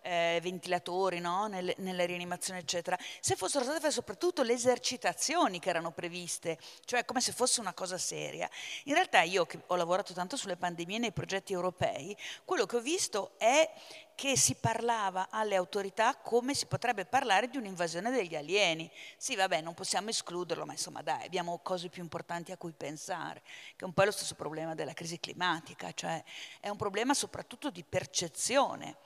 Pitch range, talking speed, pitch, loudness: 175-240 Hz, 180 wpm, 185 Hz, -33 LUFS